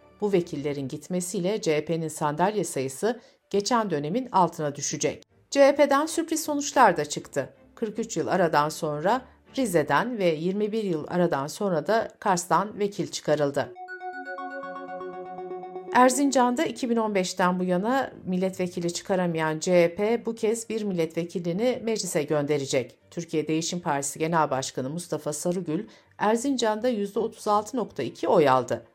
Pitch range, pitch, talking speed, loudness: 155-225 Hz, 185 Hz, 110 wpm, -26 LUFS